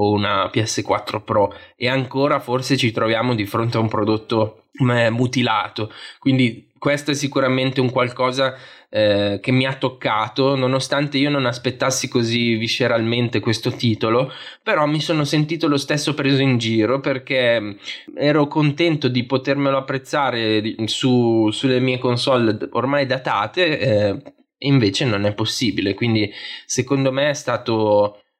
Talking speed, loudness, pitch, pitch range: 135 wpm, -19 LUFS, 125 Hz, 115-135 Hz